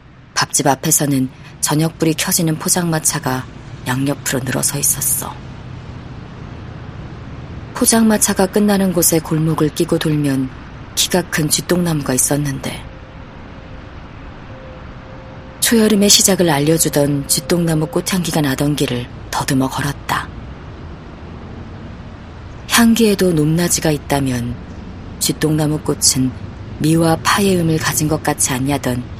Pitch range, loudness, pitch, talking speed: 125-165 Hz, -15 LUFS, 145 Hz, 240 characters per minute